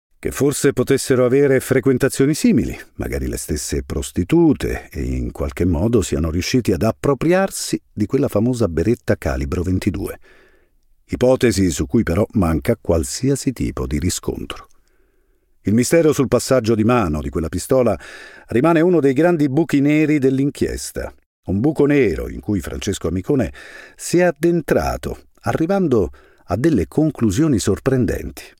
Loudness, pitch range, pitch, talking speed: -18 LUFS, 95-140 Hz, 125 Hz, 135 wpm